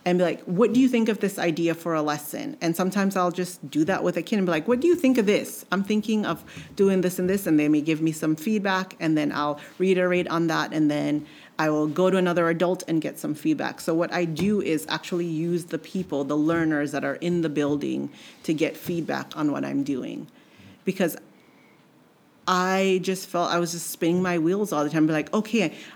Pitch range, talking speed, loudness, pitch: 155-190 Hz, 235 wpm, -24 LUFS, 175 Hz